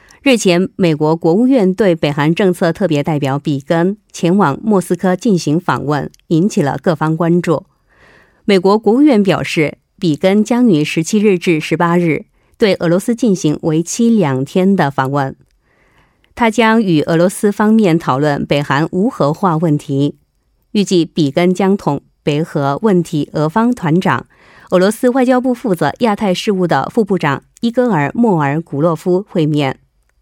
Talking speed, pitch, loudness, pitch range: 240 characters per minute, 175 Hz, -14 LUFS, 155-205 Hz